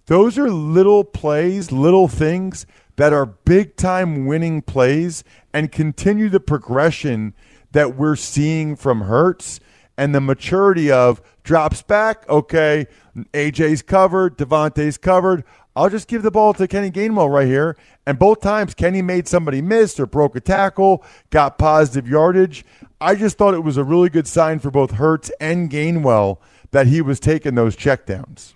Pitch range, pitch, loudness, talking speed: 140-185 Hz, 155 Hz, -16 LUFS, 160 wpm